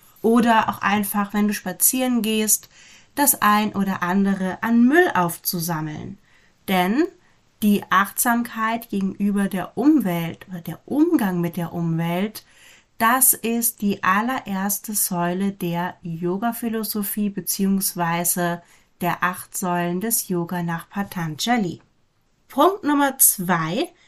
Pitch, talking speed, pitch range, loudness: 200 Hz, 110 wpm, 175-225 Hz, -21 LUFS